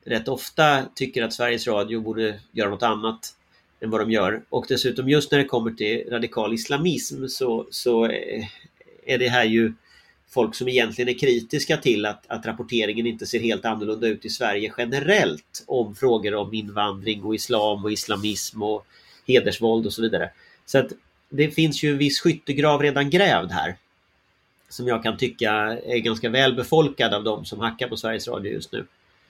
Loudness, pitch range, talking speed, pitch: -23 LUFS, 110-130 Hz, 175 wpm, 115 Hz